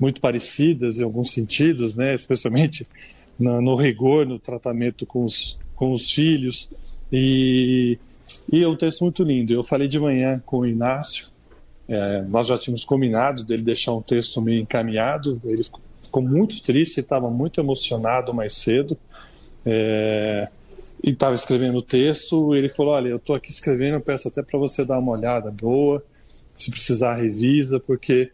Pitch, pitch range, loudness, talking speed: 125 Hz, 120-140 Hz, -21 LUFS, 165 wpm